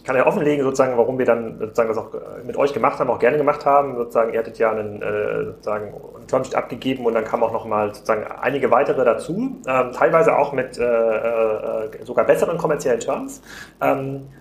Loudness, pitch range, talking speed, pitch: -20 LUFS, 115-145 Hz, 200 wpm, 130 Hz